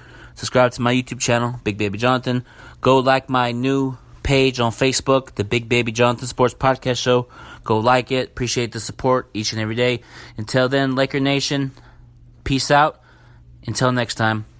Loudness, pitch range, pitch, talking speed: -19 LUFS, 120-130 Hz, 125 Hz, 170 wpm